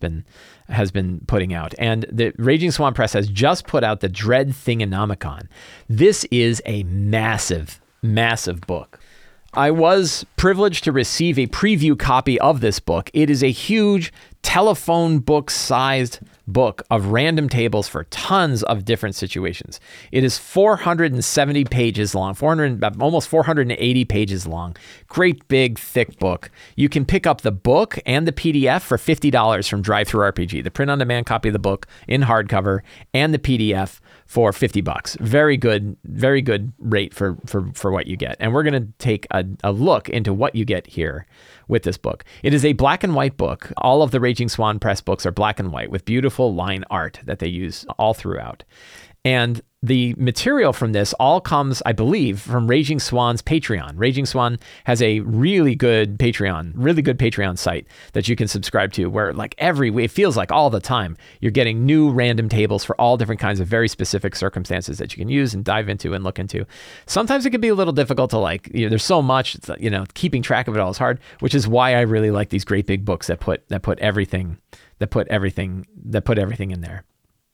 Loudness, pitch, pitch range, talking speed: -19 LUFS, 115 Hz, 100-135 Hz, 195 wpm